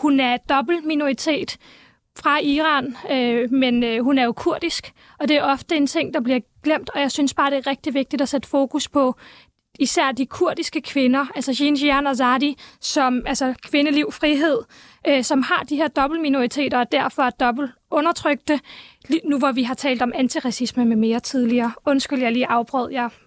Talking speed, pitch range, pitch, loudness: 190 wpm, 255-295 Hz, 275 Hz, -20 LUFS